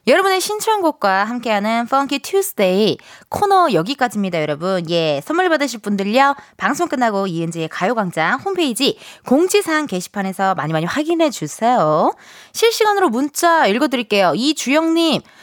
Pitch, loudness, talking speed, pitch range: 250 Hz, -17 LUFS, 360 characters per minute, 195-325 Hz